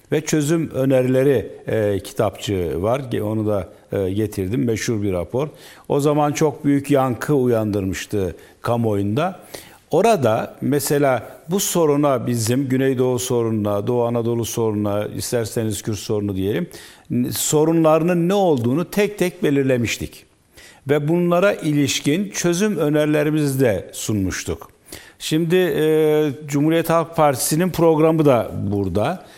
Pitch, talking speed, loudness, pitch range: 135 Hz, 110 wpm, -19 LUFS, 110-155 Hz